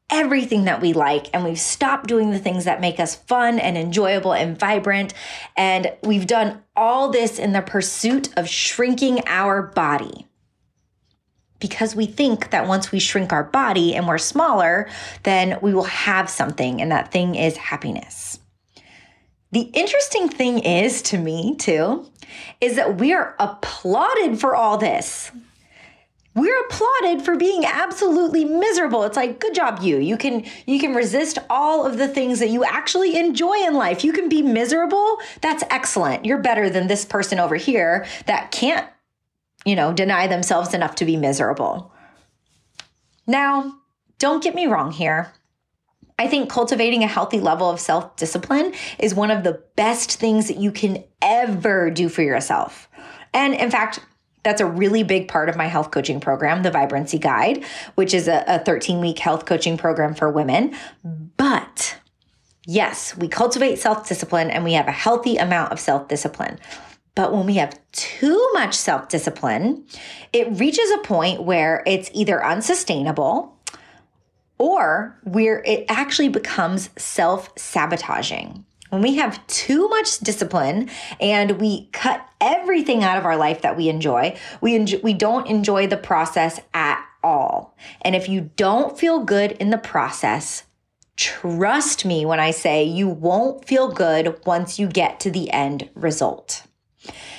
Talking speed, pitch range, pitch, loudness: 160 wpm, 175-265 Hz, 210 Hz, -20 LUFS